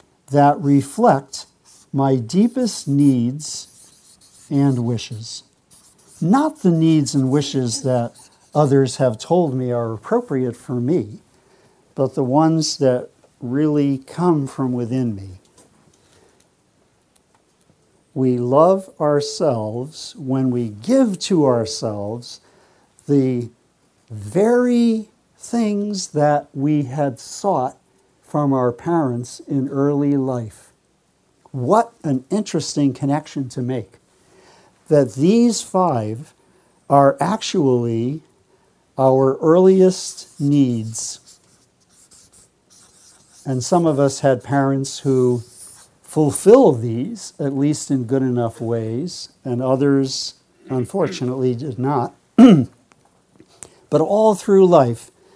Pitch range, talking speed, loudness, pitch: 125-155 Hz, 95 wpm, -18 LUFS, 140 Hz